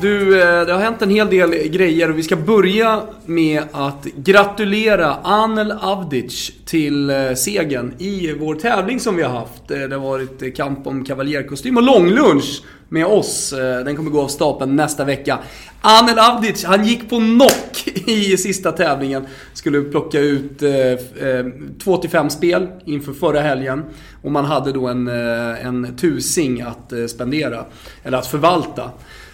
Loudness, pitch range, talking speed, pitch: -16 LUFS, 135-195 Hz, 145 wpm, 155 Hz